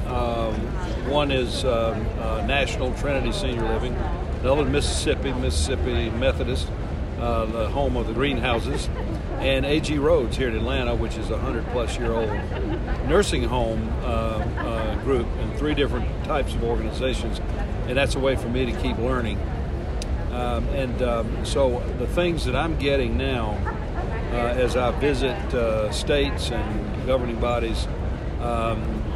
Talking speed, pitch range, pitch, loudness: 150 wpm, 80-120 Hz, 115 Hz, -25 LUFS